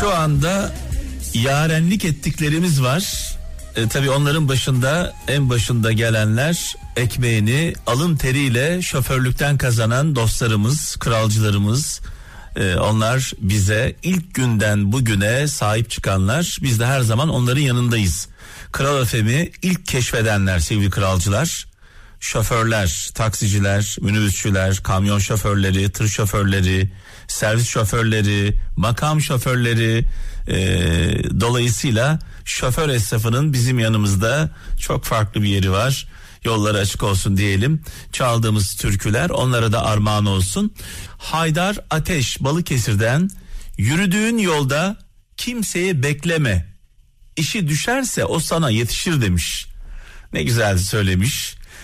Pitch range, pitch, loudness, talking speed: 100-140 Hz, 115 Hz, -19 LUFS, 100 wpm